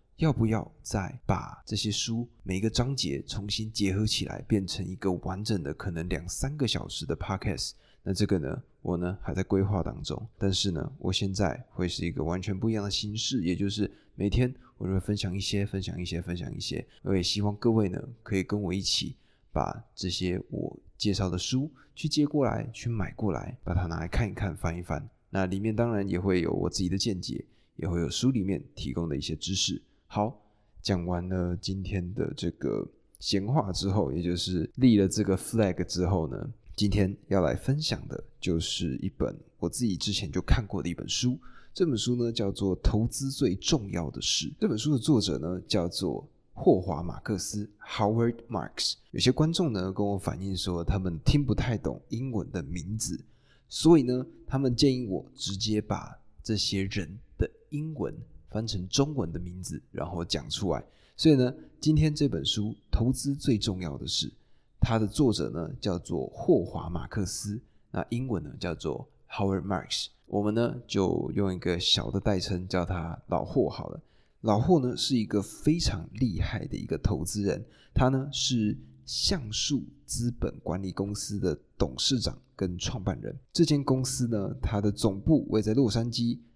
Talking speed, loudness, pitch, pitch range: 280 characters per minute, -29 LUFS, 100 Hz, 90-120 Hz